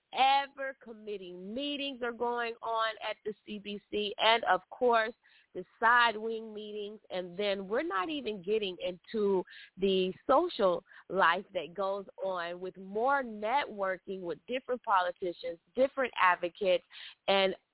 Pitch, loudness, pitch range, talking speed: 205 Hz, -32 LUFS, 185-230 Hz, 130 wpm